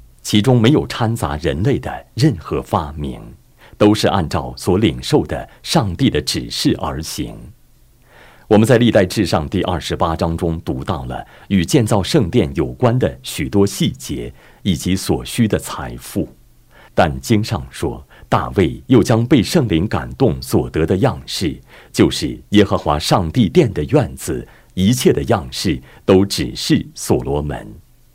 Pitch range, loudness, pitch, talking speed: 75-110 Hz, -17 LUFS, 95 Hz, 220 characters per minute